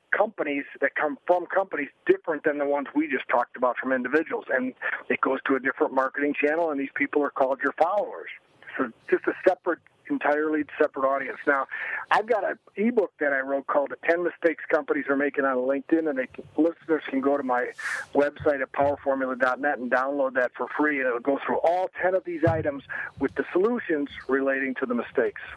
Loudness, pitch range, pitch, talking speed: -26 LUFS, 135-165 Hz, 145 Hz, 200 wpm